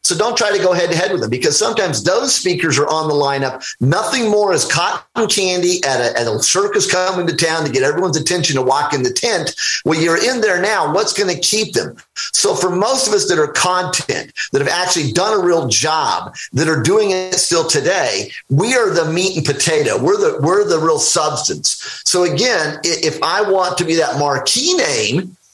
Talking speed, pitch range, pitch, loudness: 220 wpm, 160-215 Hz, 180 Hz, -15 LUFS